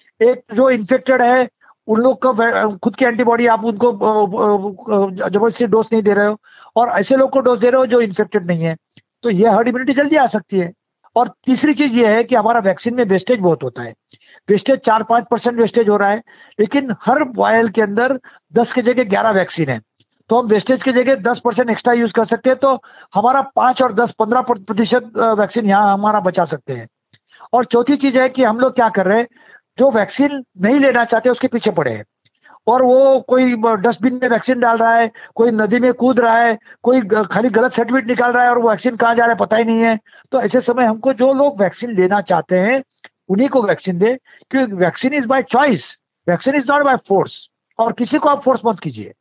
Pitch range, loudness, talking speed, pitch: 215-255 Hz, -15 LUFS, 220 wpm, 235 Hz